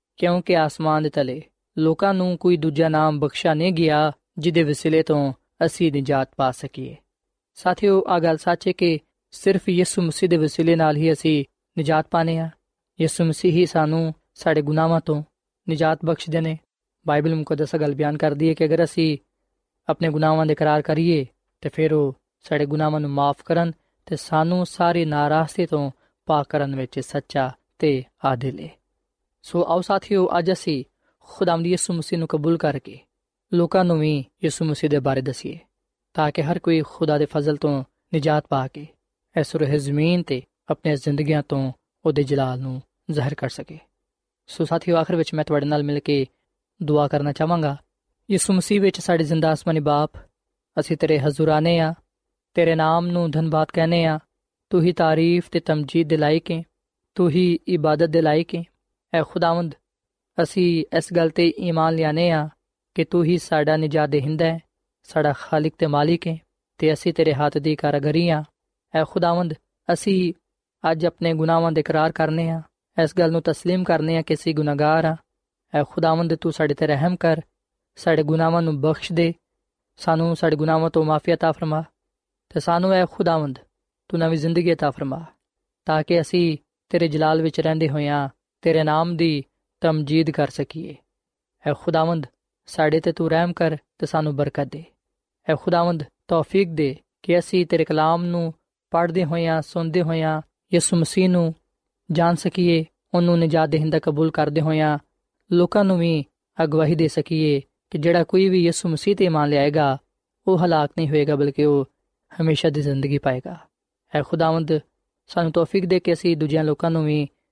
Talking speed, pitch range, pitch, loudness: 170 wpm, 150-170 Hz, 160 Hz, -21 LUFS